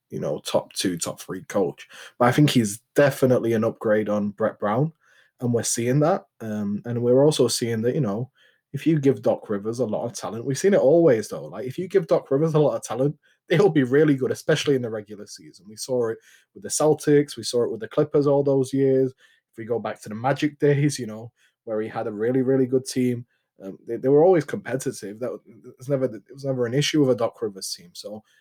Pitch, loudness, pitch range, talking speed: 130 Hz, -23 LUFS, 115-145 Hz, 245 wpm